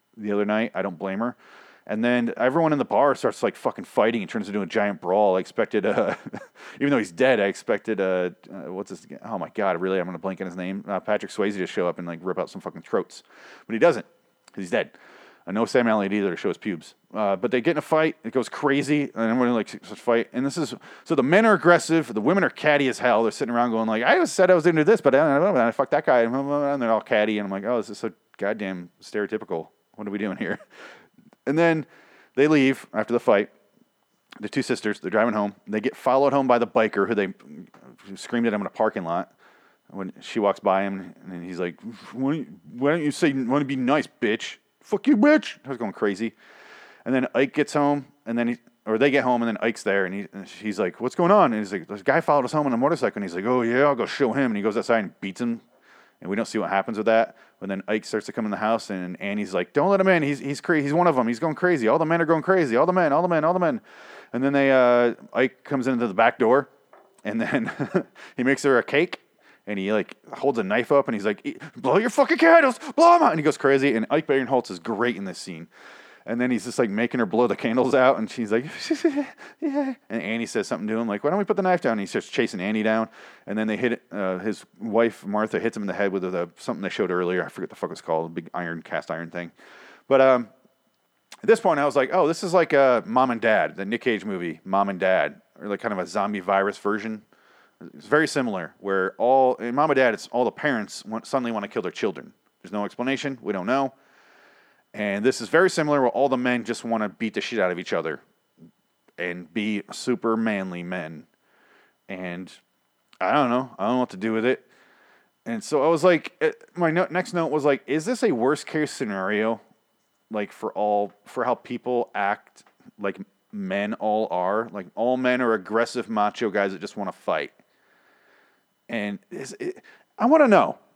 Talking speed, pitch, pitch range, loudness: 250 wpm, 120 Hz, 105-145 Hz, -23 LUFS